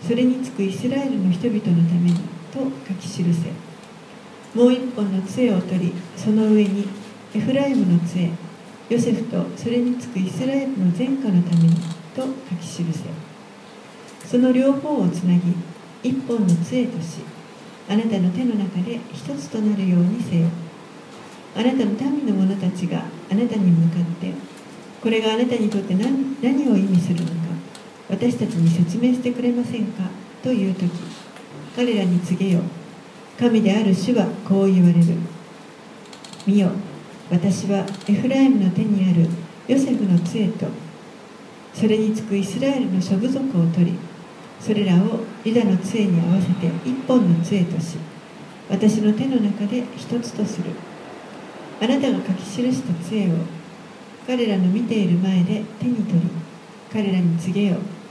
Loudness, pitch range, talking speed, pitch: -21 LUFS, 175-235 Hz, 280 characters per minute, 205 Hz